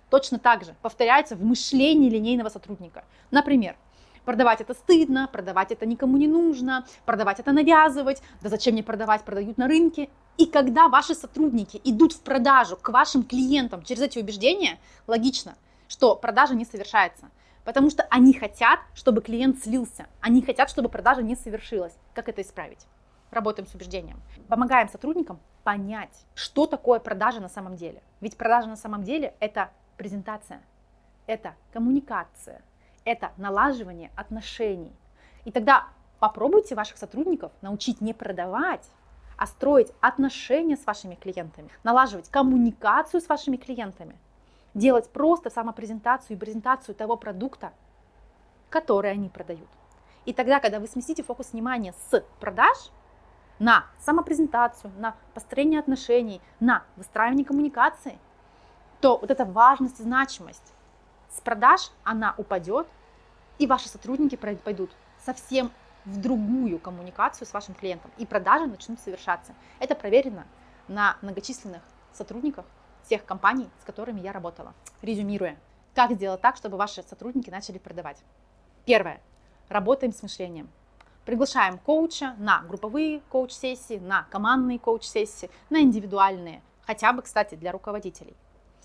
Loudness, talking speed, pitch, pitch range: -24 LUFS, 130 wpm, 235 Hz, 205-265 Hz